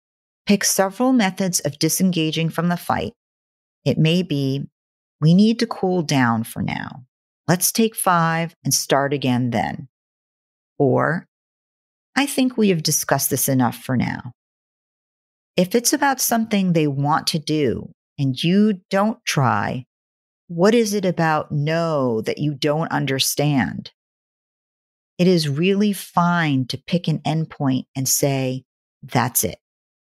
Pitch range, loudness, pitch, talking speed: 135-190 Hz, -20 LUFS, 160 Hz, 135 wpm